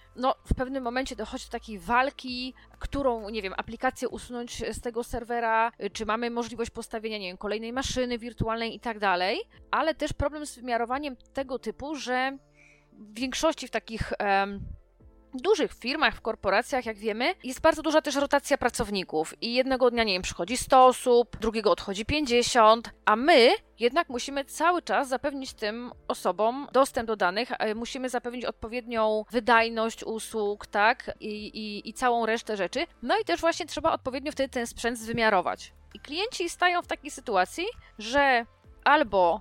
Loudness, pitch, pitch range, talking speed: -27 LUFS, 240 Hz, 220-270 Hz, 160 wpm